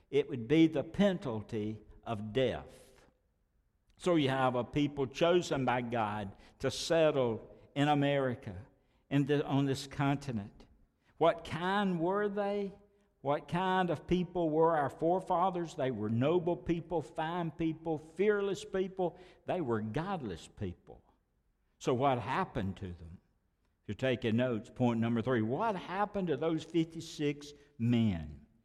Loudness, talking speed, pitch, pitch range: -33 LUFS, 135 wpm, 145 Hz, 120-175 Hz